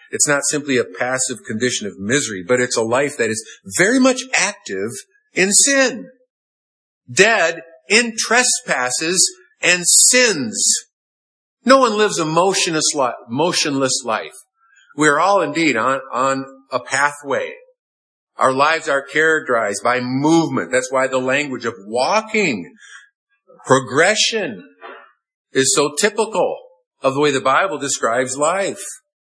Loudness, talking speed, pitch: -16 LUFS, 125 wpm, 160 Hz